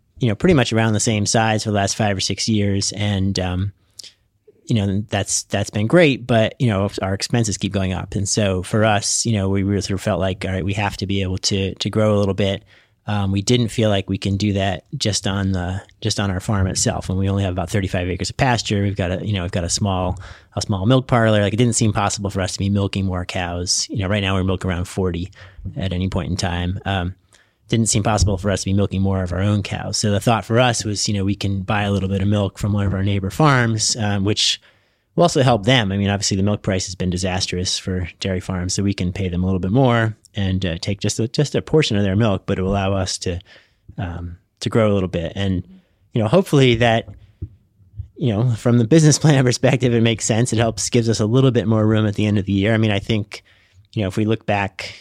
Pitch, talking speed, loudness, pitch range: 100 Hz, 270 wpm, -19 LUFS, 95-110 Hz